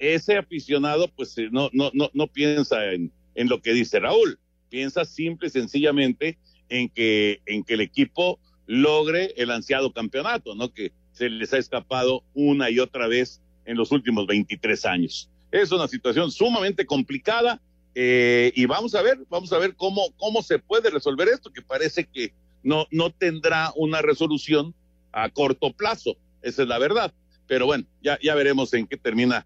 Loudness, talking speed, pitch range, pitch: -23 LUFS, 175 wpm, 115-160 Hz, 135 Hz